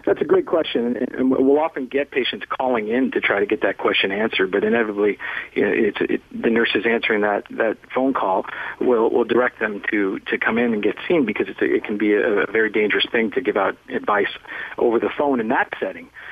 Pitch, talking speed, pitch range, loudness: 125 Hz, 230 wpm, 105-135 Hz, -20 LUFS